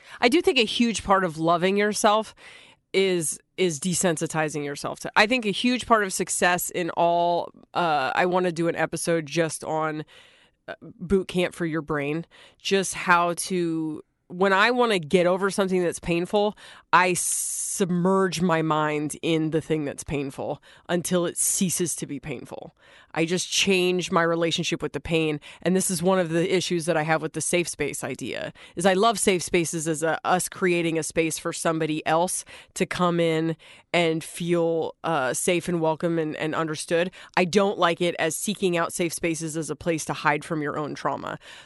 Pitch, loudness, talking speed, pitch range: 170 Hz, -24 LUFS, 190 wpm, 160-185 Hz